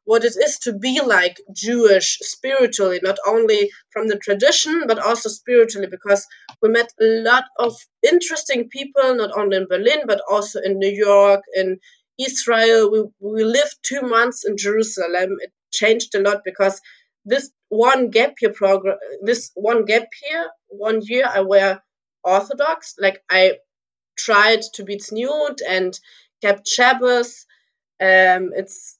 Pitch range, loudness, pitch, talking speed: 195-250 Hz, -18 LUFS, 220 Hz, 150 wpm